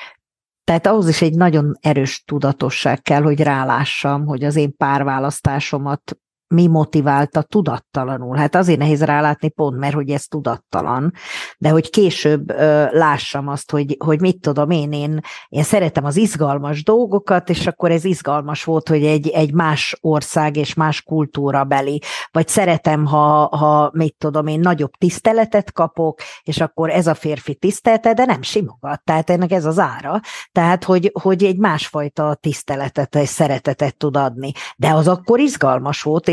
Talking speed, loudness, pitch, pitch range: 155 wpm, -17 LUFS, 155 Hz, 145-170 Hz